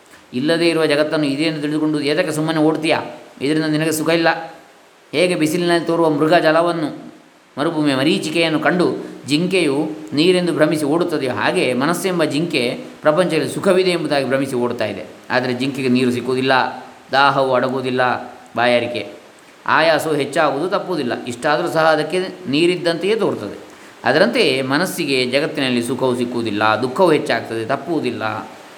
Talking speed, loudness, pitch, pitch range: 115 wpm, -17 LUFS, 150 Hz, 130-165 Hz